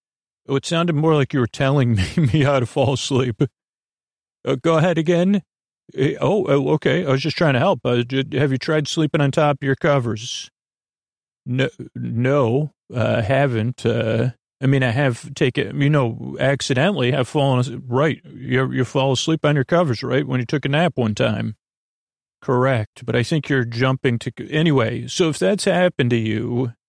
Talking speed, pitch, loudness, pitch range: 180 wpm, 135 Hz, -20 LUFS, 120-150 Hz